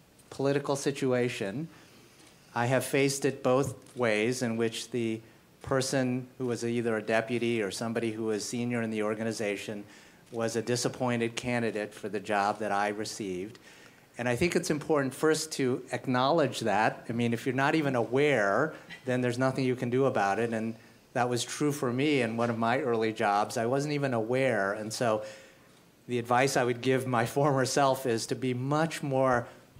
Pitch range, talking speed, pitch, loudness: 115-135 Hz, 180 wpm, 120 Hz, -29 LUFS